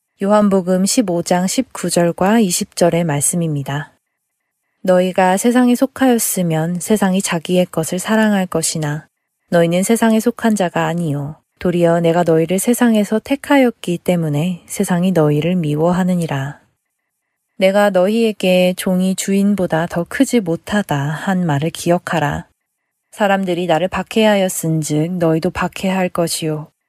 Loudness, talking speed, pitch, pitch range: -16 LUFS, 290 characters per minute, 180 Hz, 165-200 Hz